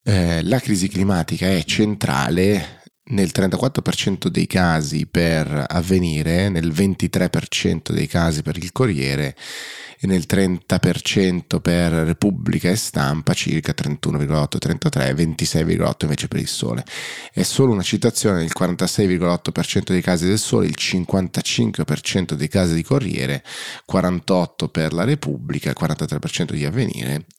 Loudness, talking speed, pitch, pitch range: -20 LUFS, 125 wpm, 90 Hz, 80-100 Hz